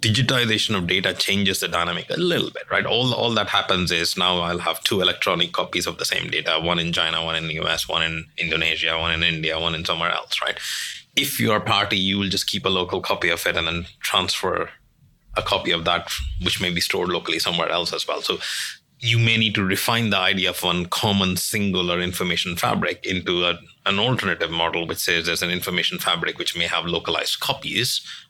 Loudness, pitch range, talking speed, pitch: -21 LUFS, 85-100 Hz, 215 wpm, 90 Hz